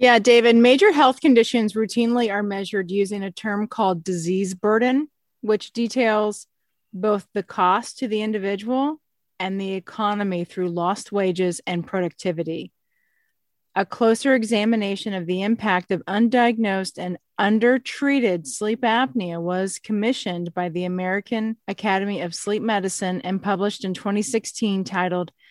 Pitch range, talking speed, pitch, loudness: 185-230 Hz, 130 wpm, 205 Hz, -22 LUFS